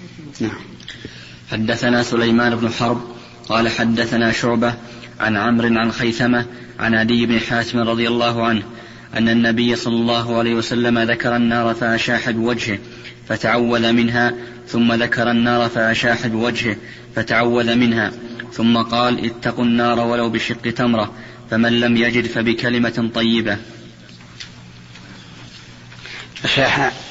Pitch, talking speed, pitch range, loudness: 115 Hz, 110 wpm, 115-120 Hz, -17 LUFS